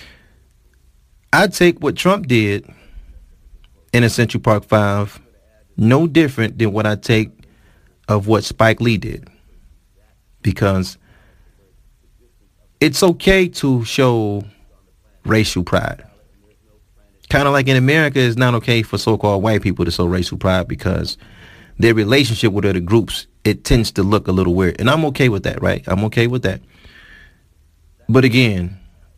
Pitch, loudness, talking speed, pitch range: 105 Hz, -16 LUFS, 140 wpm, 95-120 Hz